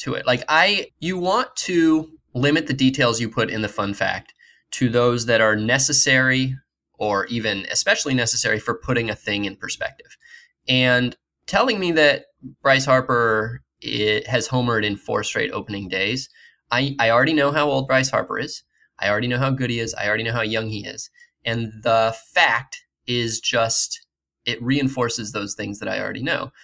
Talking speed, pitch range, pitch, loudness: 180 wpm, 110-140 Hz, 120 Hz, -20 LUFS